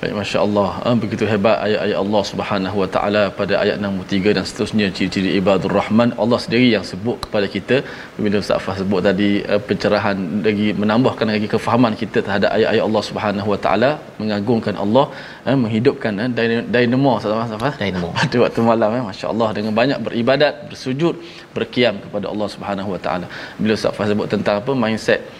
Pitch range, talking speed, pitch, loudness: 100-120 Hz, 170 wpm, 105 Hz, -18 LUFS